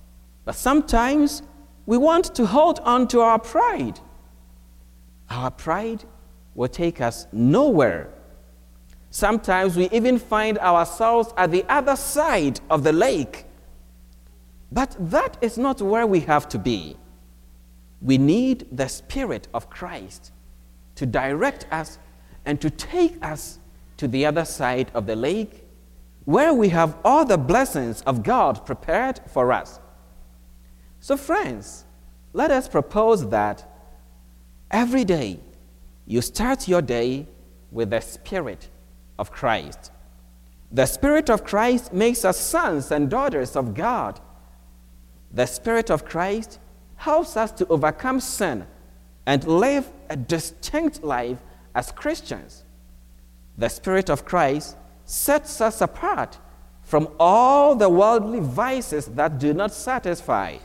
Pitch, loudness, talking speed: 140 Hz, -21 LUFS, 125 wpm